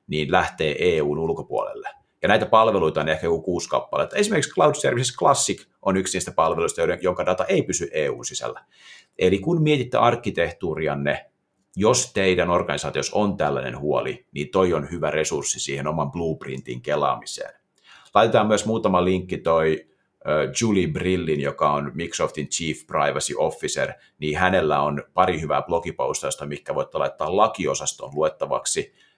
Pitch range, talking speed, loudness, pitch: 75-120 Hz, 140 wpm, -23 LUFS, 90 Hz